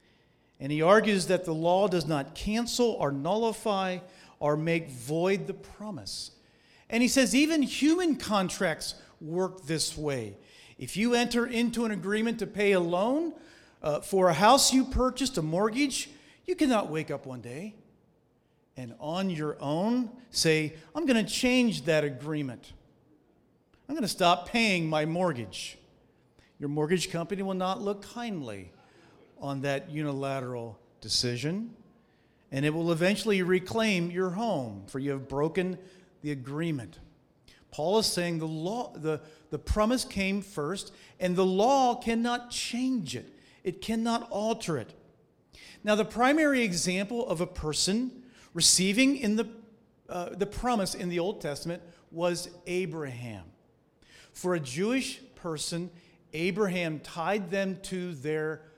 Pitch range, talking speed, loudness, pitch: 155-225 Hz, 140 wpm, -29 LUFS, 185 Hz